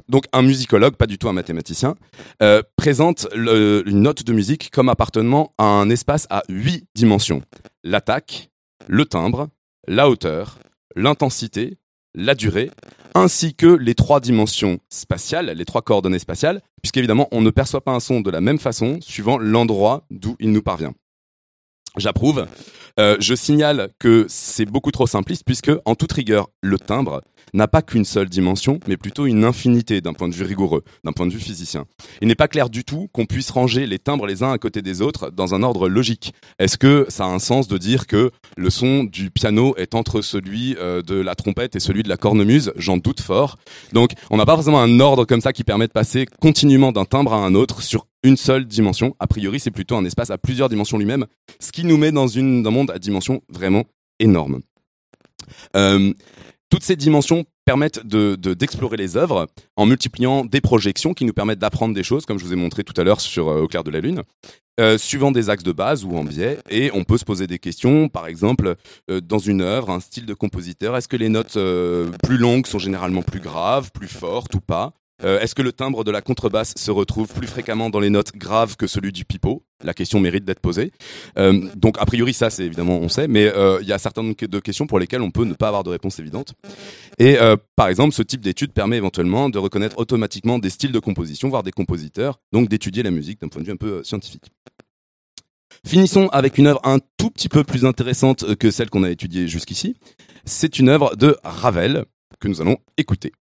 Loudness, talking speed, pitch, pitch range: -18 LUFS, 215 wpm, 110 Hz, 100-130 Hz